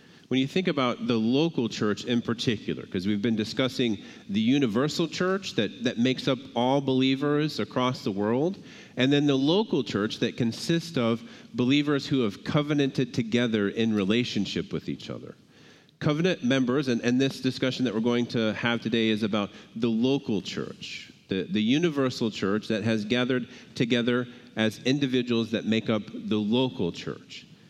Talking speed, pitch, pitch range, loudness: 165 wpm, 125 Hz, 115-140 Hz, -27 LUFS